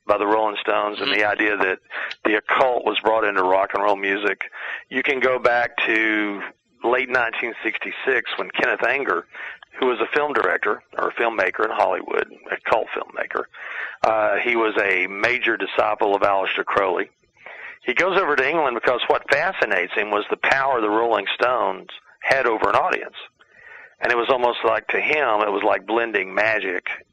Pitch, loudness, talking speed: 115 Hz, -21 LUFS, 180 wpm